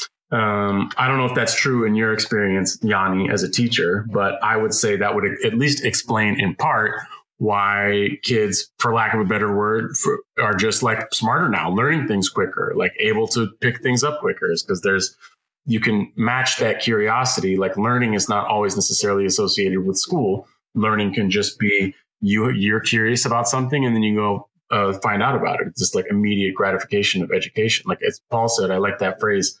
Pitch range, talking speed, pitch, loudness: 100-120 Hz, 200 wpm, 105 Hz, -19 LUFS